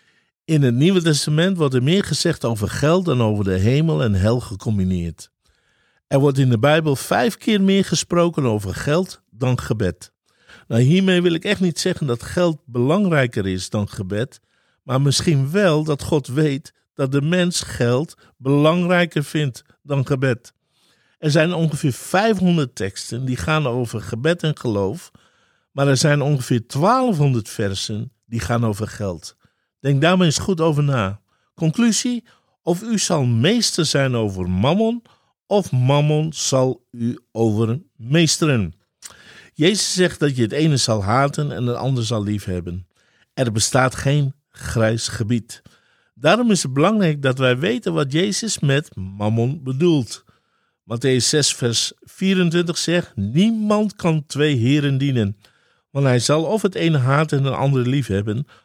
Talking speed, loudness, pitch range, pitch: 150 wpm, -19 LUFS, 115-165 Hz, 140 Hz